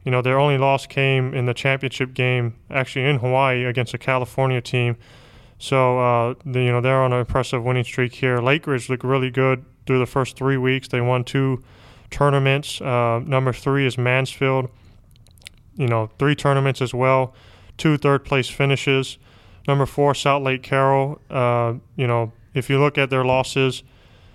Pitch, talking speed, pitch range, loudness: 130 Hz, 175 wpm, 125-135 Hz, -20 LUFS